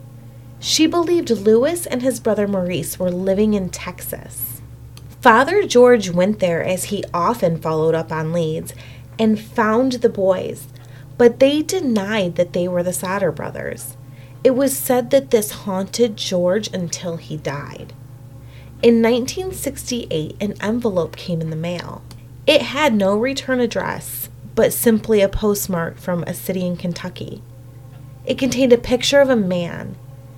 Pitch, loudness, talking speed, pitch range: 185 Hz, -18 LUFS, 145 wpm, 155-235 Hz